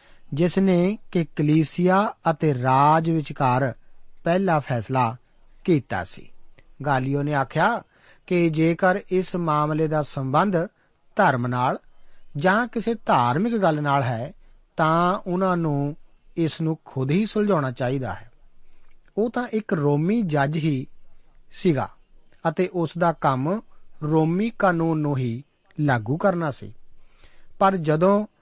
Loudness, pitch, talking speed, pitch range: -23 LUFS, 160 Hz, 120 wpm, 135-185 Hz